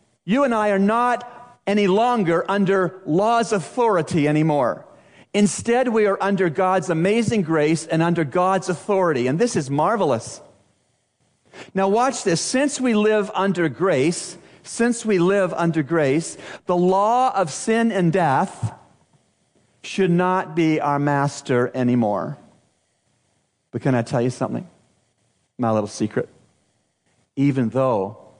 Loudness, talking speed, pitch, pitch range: -20 LUFS, 130 wpm, 185 Hz, 155-210 Hz